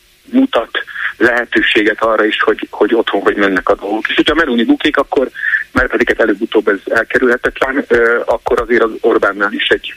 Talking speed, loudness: 170 wpm, -13 LUFS